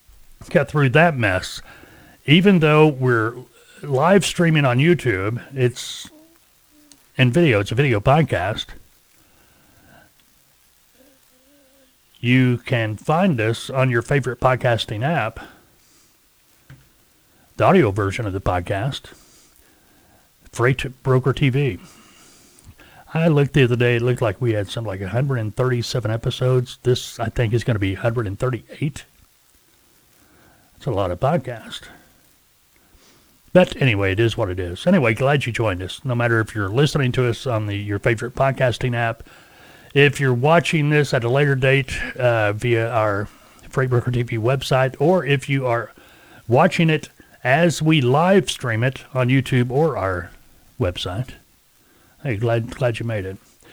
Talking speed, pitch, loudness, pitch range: 140 wpm, 125 Hz, -19 LUFS, 115-140 Hz